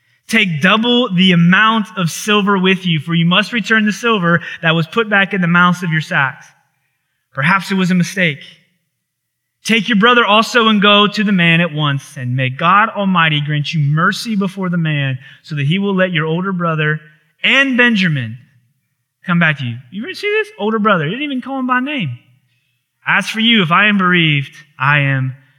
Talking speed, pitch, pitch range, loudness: 200 wpm, 175 Hz, 150-210 Hz, -13 LUFS